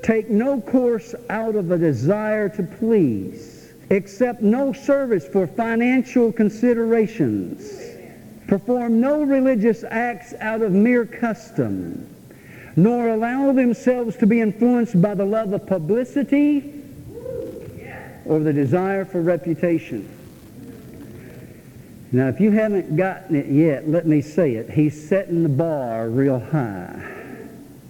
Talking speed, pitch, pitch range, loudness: 120 wpm, 210 Hz, 165-235 Hz, -20 LUFS